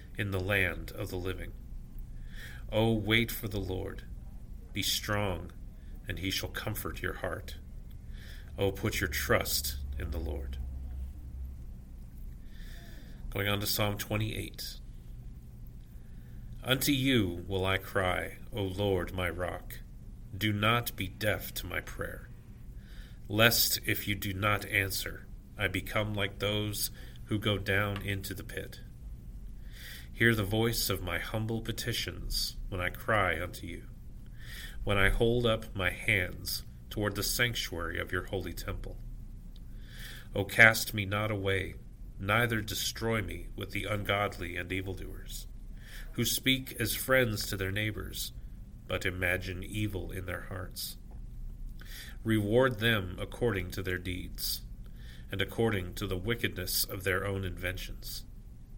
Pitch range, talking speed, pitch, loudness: 90-110 Hz, 135 wpm, 100 Hz, -32 LUFS